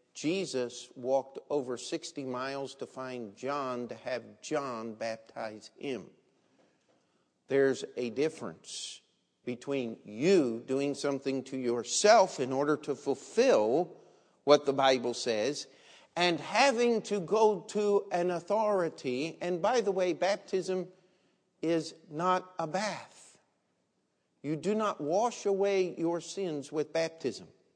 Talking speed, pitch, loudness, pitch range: 120 wpm, 150 Hz, -31 LUFS, 130-185 Hz